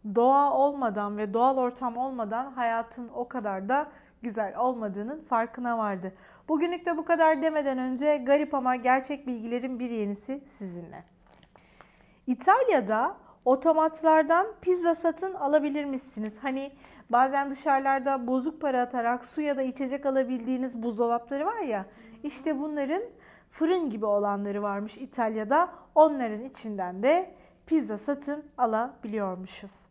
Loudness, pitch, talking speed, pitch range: -28 LUFS, 255 Hz, 120 wpm, 230-290 Hz